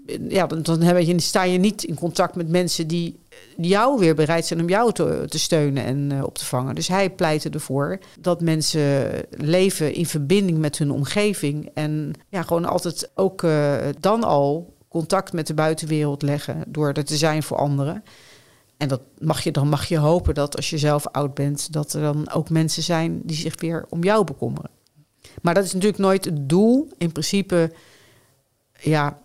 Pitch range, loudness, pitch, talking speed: 145-175 Hz, -21 LUFS, 160 Hz, 190 wpm